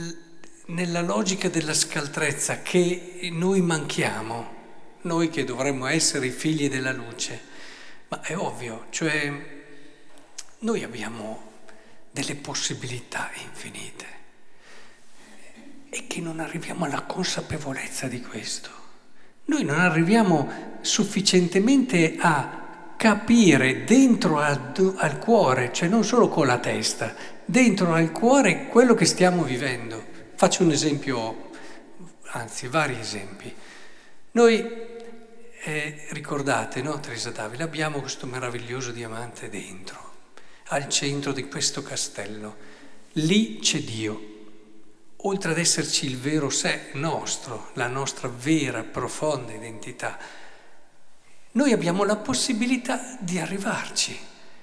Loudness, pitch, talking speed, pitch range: -24 LUFS, 155 Hz, 110 wpm, 130-185 Hz